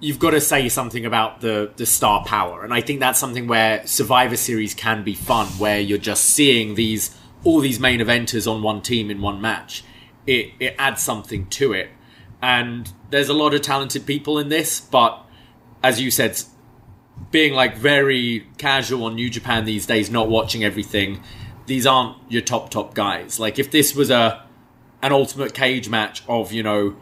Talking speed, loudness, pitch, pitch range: 190 wpm, -19 LUFS, 120 Hz, 110-130 Hz